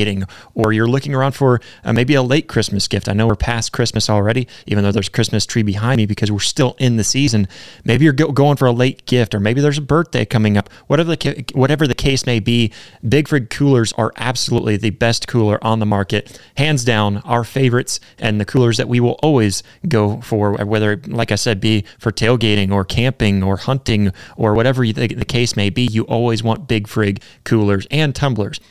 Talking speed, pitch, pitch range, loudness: 215 wpm, 115 Hz, 105-130 Hz, -16 LUFS